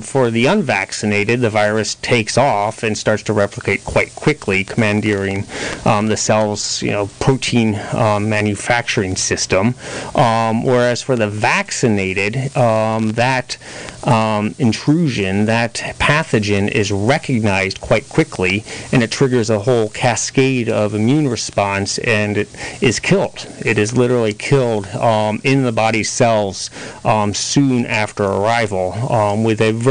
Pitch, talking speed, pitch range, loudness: 110 Hz, 135 wpm, 105-125 Hz, -16 LUFS